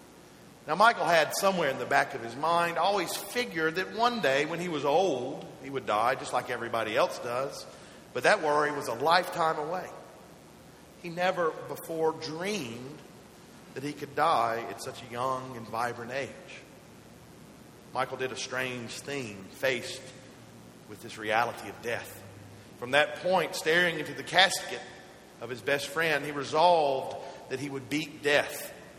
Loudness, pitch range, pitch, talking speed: -29 LUFS, 130-170 Hz, 145 Hz, 160 wpm